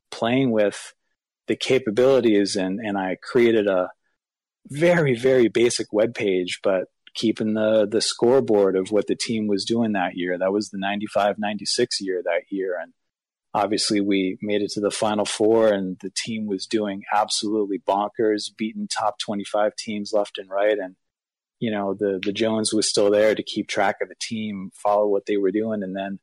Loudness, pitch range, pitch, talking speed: -22 LUFS, 100-110 Hz, 105 Hz, 180 wpm